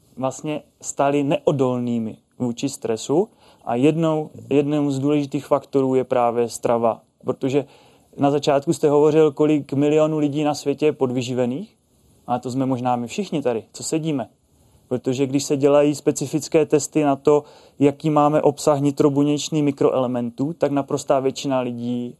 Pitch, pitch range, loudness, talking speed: 140 Hz, 130-150 Hz, -21 LUFS, 140 wpm